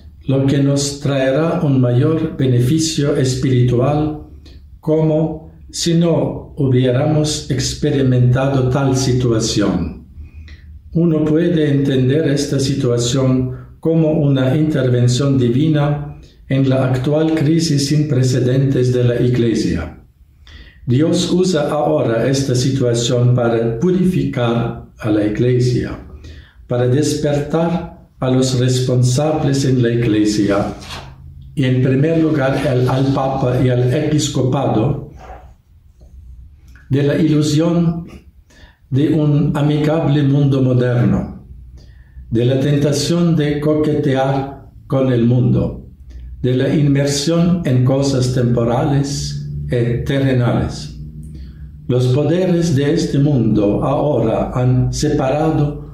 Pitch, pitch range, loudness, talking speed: 130 Hz, 115-150 Hz, -16 LUFS, 100 wpm